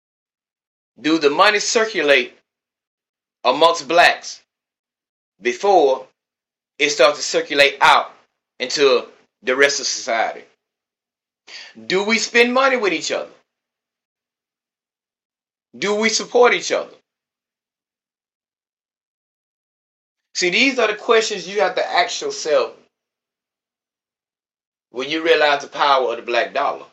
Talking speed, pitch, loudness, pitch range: 105 wpm, 220 Hz, -17 LUFS, 180-290 Hz